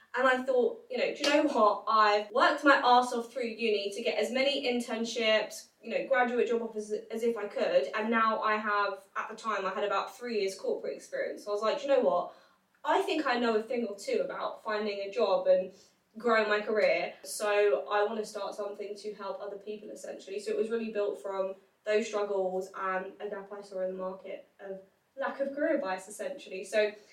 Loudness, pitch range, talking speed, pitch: -30 LUFS, 200-245 Hz, 225 wpm, 215 Hz